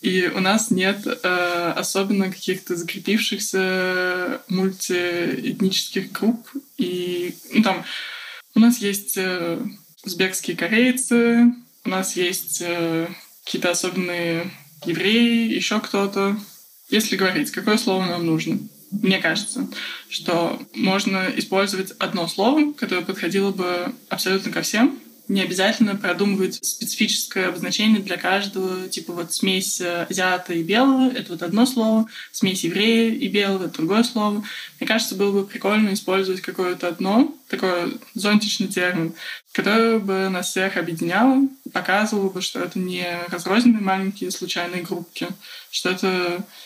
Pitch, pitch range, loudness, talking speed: 195 Hz, 180-220 Hz, -21 LUFS, 125 wpm